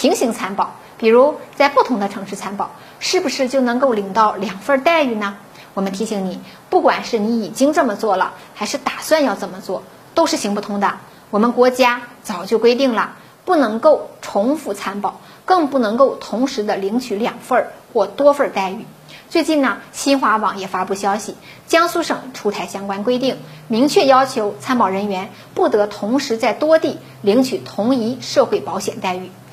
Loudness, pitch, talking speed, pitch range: -18 LUFS, 230 Hz, 270 characters per minute, 200-275 Hz